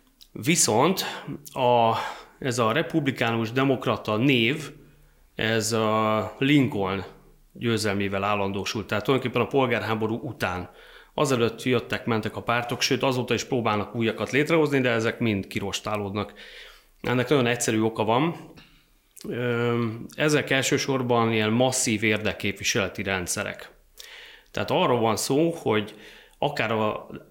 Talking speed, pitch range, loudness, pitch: 110 wpm, 105-130 Hz, -24 LUFS, 115 Hz